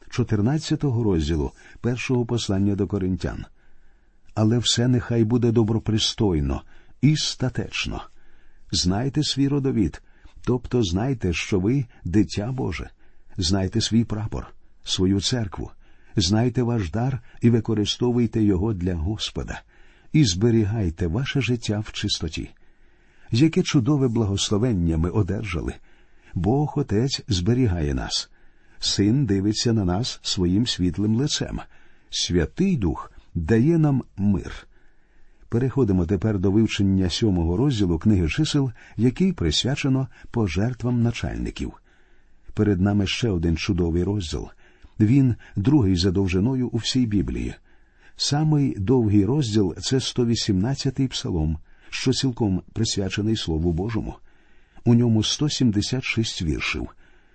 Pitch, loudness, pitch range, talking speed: 110 Hz, -23 LUFS, 95-125 Hz, 105 wpm